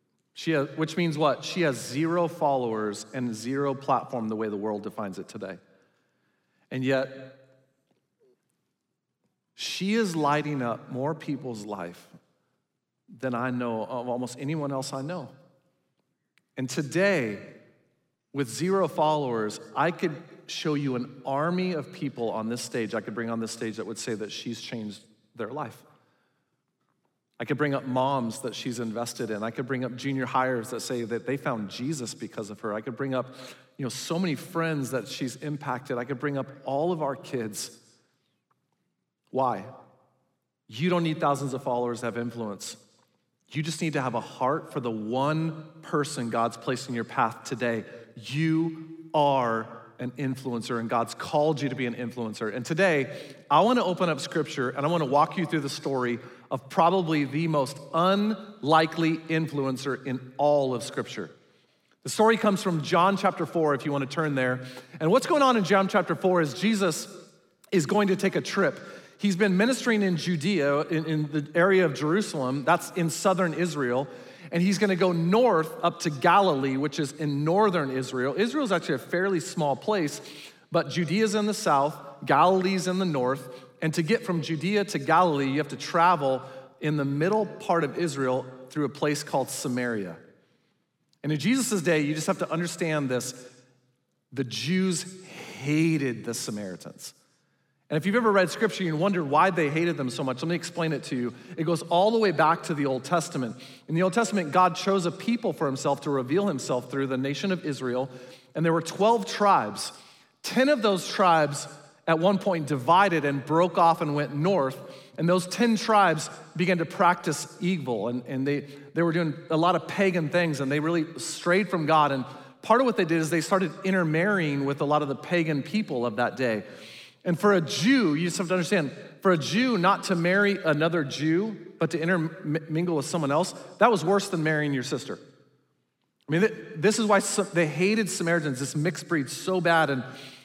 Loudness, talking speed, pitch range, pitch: -26 LUFS, 190 wpm, 130-180 Hz, 155 Hz